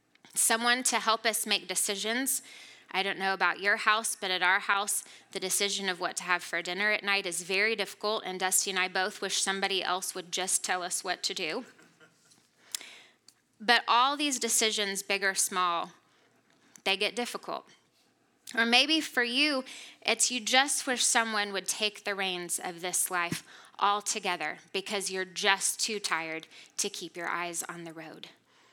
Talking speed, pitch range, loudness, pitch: 175 wpm, 185-225 Hz, -28 LUFS, 200 Hz